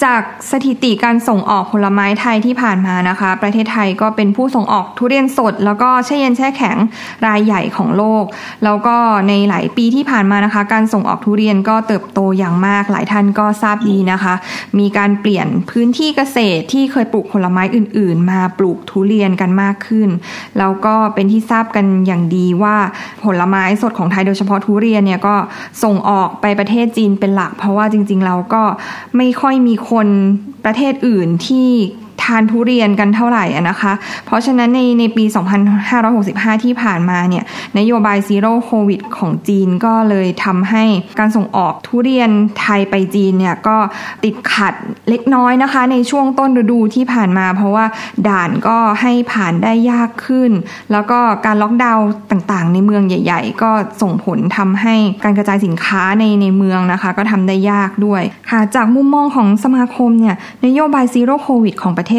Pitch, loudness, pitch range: 215 Hz, -13 LUFS, 200-235 Hz